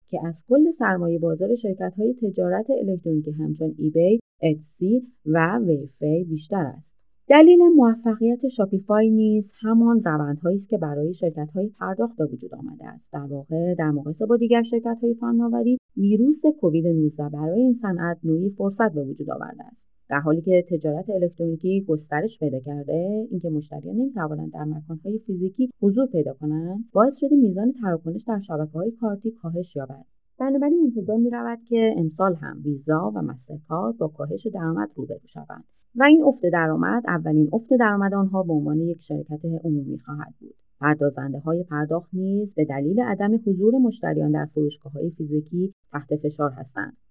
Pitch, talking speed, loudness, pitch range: 175 Hz, 160 wpm, -22 LUFS, 150-225 Hz